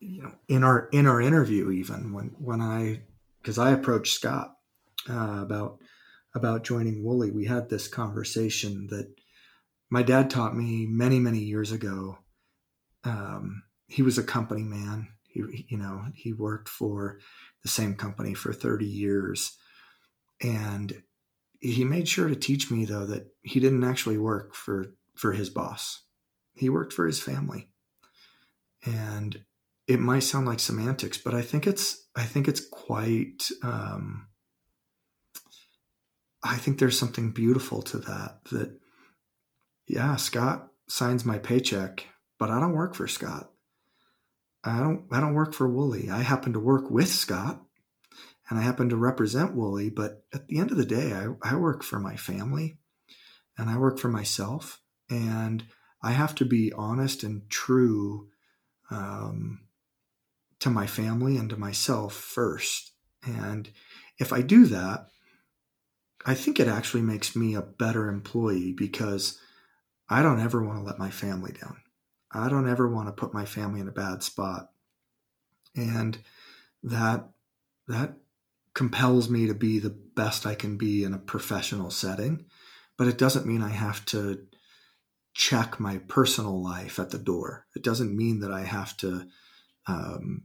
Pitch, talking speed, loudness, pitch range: 115 Hz, 155 wpm, -28 LUFS, 105-125 Hz